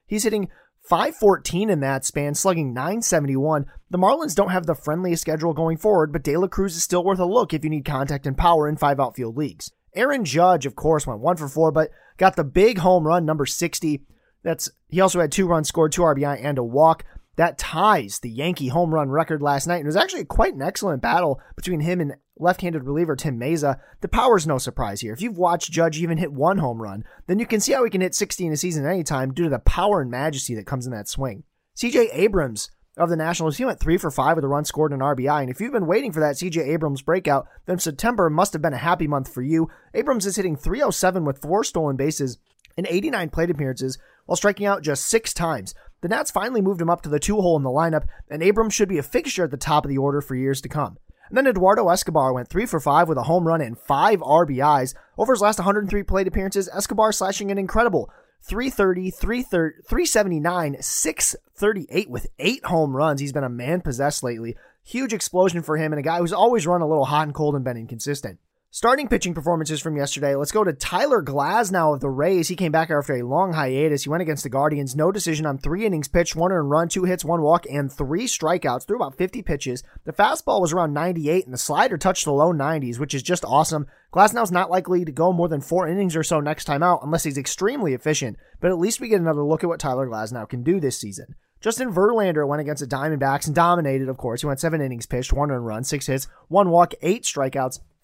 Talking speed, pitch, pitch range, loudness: 235 wpm, 165 Hz, 145-185 Hz, -22 LUFS